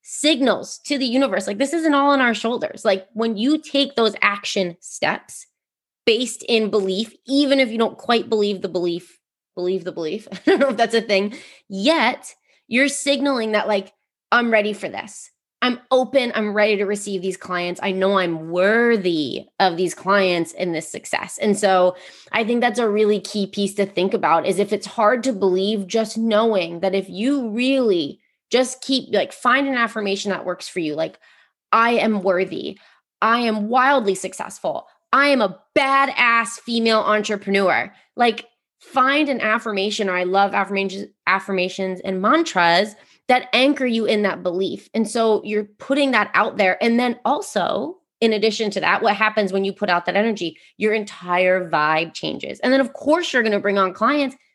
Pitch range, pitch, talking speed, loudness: 195-245 Hz, 215 Hz, 185 wpm, -20 LUFS